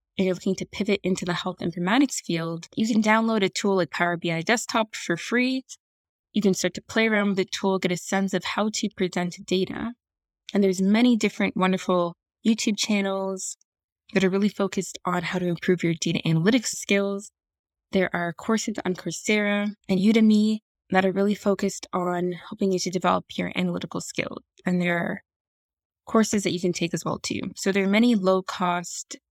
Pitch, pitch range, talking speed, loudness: 195 Hz, 180-215 Hz, 190 wpm, -24 LUFS